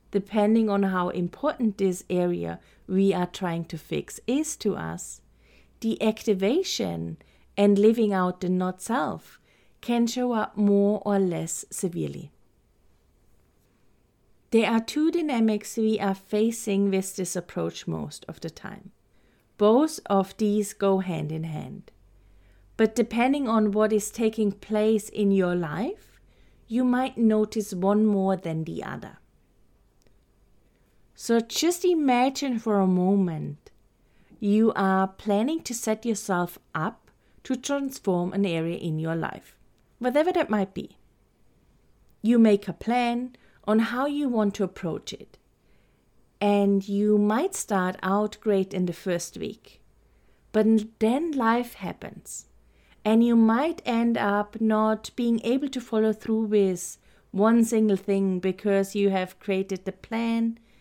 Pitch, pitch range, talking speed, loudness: 210 Hz, 190-230 Hz, 135 wpm, -25 LUFS